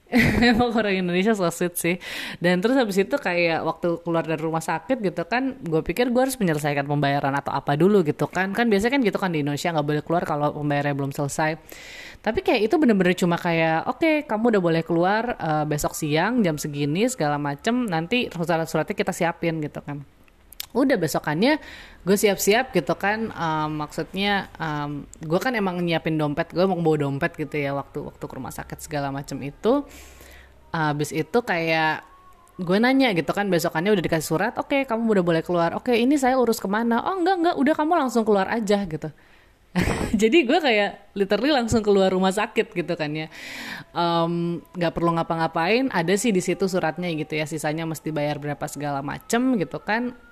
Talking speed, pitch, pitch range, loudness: 190 wpm, 175 Hz, 155-225 Hz, -23 LUFS